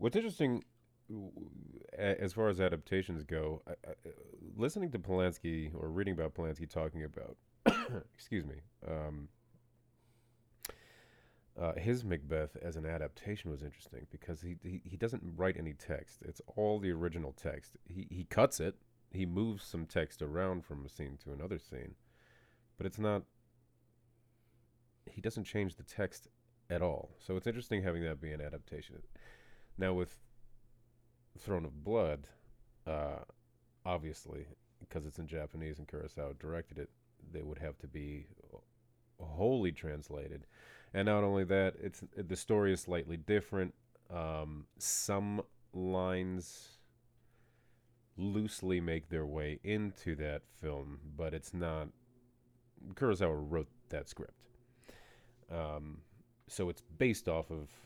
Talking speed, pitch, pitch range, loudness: 135 wpm, 90 Hz, 80-110 Hz, -39 LUFS